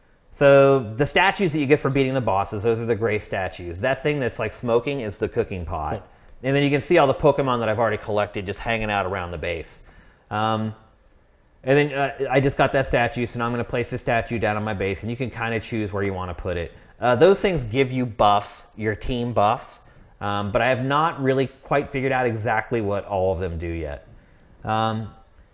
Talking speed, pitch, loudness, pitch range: 235 wpm, 115 Hz, -22 LUFS, 105-135 Hz